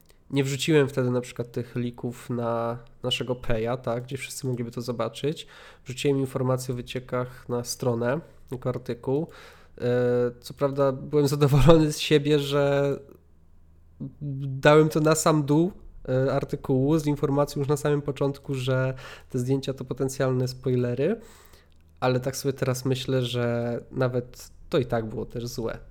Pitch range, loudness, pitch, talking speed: 120-140 Hz, -26 LUFS, 130 Hz, 145 wpm